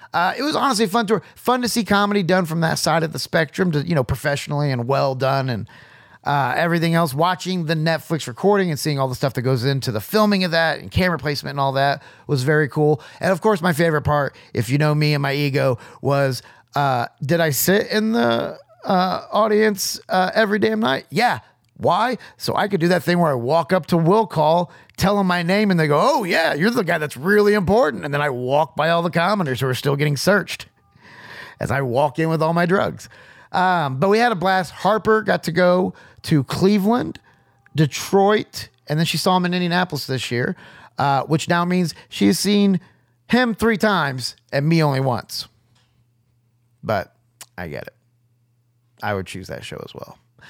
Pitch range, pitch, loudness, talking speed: 135-185 Hz, 160 Hz, -19 LUFS, 210 wpm